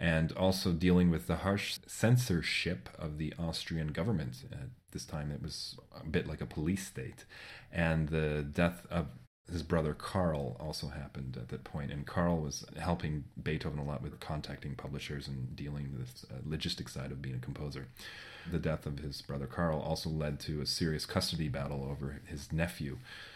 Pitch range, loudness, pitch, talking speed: 70-85 Hz, -36 LUFS, 75 Hz, 180 wpm